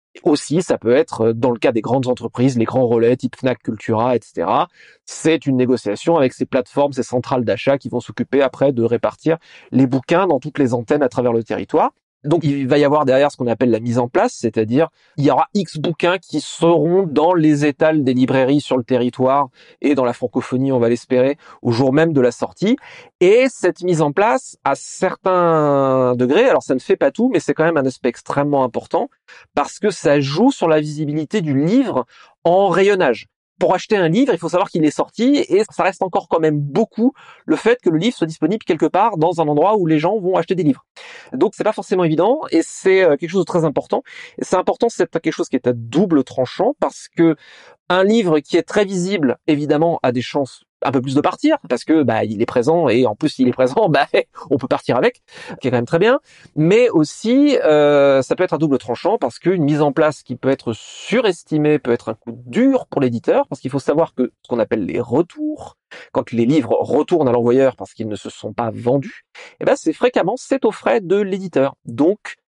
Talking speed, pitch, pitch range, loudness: 230 wpm, 150 Hz, 130-185 Hz, -17 LUFS